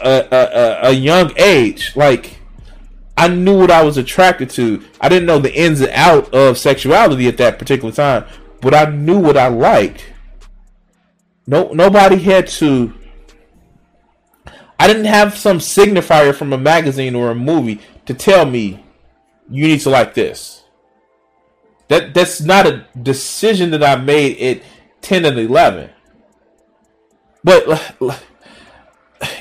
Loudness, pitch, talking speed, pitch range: -12 LUFS, 150 Hz, 140 wpm, 130-185 Hz